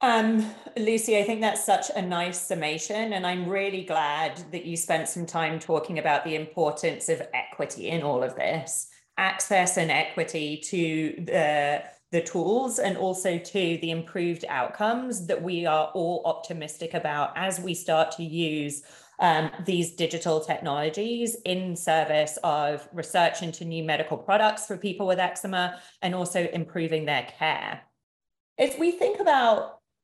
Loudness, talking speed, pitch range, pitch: -27 LUFS, 155 wpm, 160-195 Hz, 175 Hz